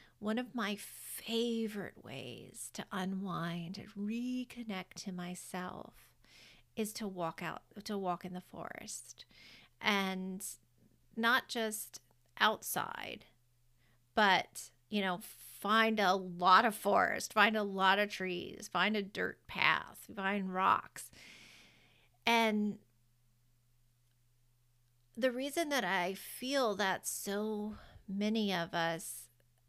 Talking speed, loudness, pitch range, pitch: 110 wpm, -35 LUFS, 170-215 Hz, 195 Hz